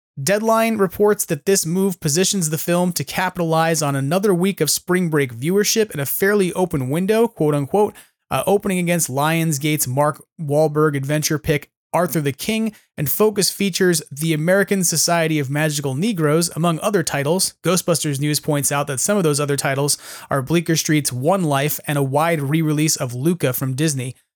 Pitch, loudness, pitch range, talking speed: 160 Hz, -19 LUFS, 145-185 Hz, 170 wpm